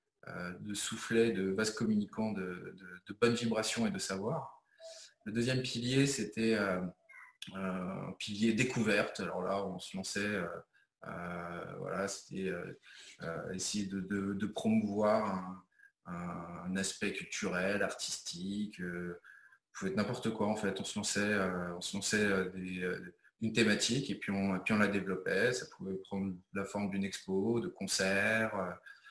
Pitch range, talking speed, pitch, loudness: 95-110 Hz, 160 wpm, 100 Hz, -35 LUFS